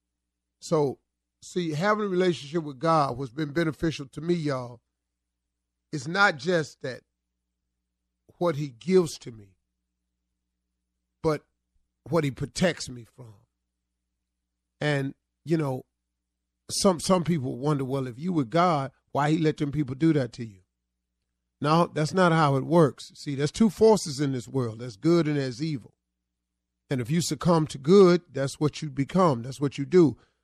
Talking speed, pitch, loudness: 160 wpm, 135 Hz, -26 LUFS